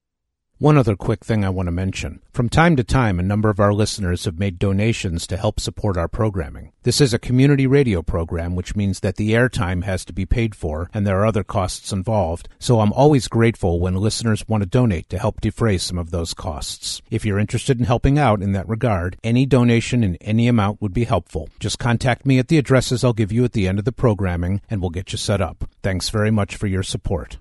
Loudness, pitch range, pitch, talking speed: -20 LUFS, 95-115 Hz, 105 Hz, 235 wpm